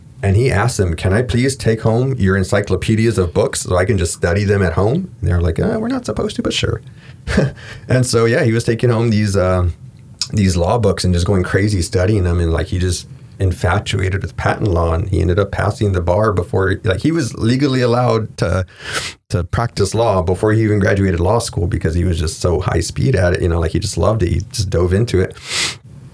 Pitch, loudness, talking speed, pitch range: 105 Hz, -16 LUFS, 230 wpm, 95-120 Hz